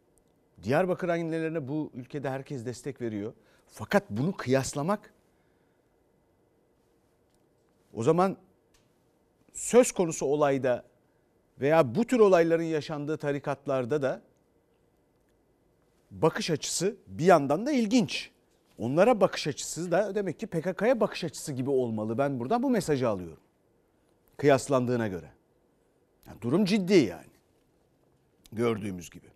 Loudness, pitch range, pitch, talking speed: -28 LUFS, 130-185 Hz, 150 Hz, 105 wpm